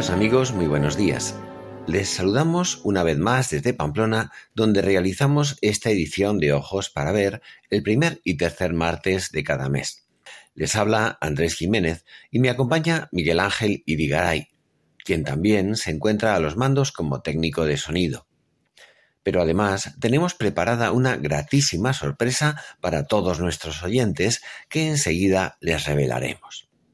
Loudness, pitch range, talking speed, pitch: -22 LUFS, 80-120 Hz, 140 wpm, 100 Hz